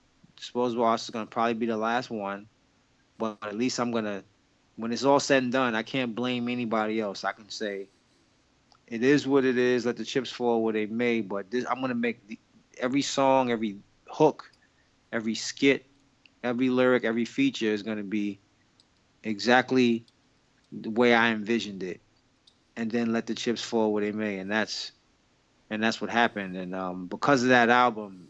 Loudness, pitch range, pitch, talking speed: -27 LUFS, 110-125 Hz, 115 Hz, 180 wpm